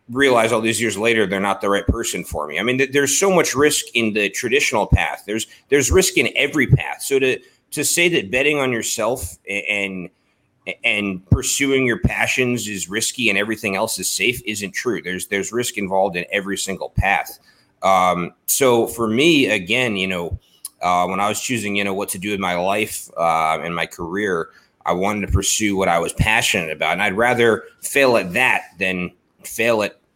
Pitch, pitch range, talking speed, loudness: 105 Hz, 95-125 Hz, 200 wpm, -18 LUFS